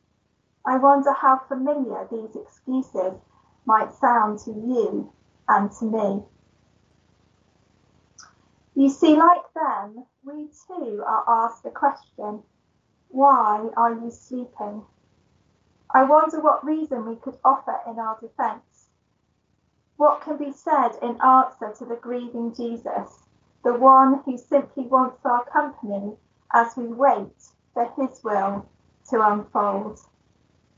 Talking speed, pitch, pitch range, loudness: 120 wpm, 255 Hz, 225-275 Hz, -21 LUFS